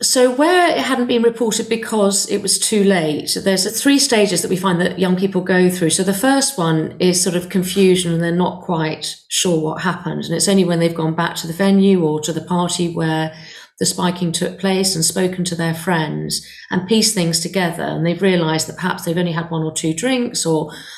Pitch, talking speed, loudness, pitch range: 180 Hz, 225 wpm, -17 LUFS, 165-195 Hz